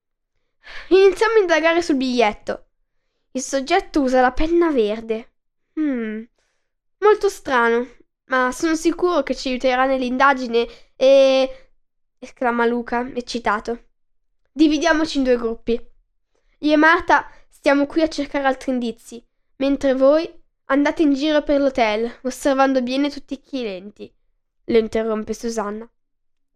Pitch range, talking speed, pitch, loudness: 235-300 Hz, 120 wpm, 265 Hz, -19 LUFS